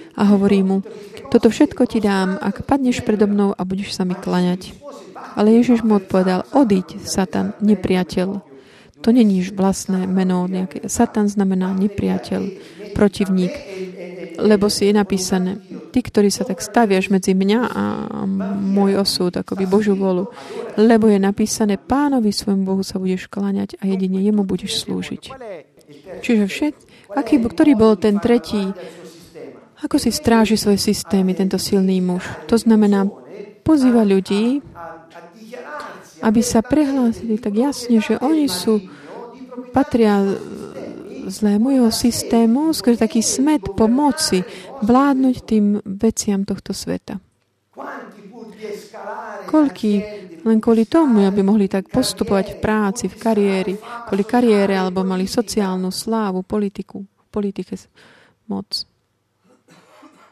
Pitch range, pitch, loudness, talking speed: 190-230 Hz, 205 Hz, -18 LUFS, 125 wpm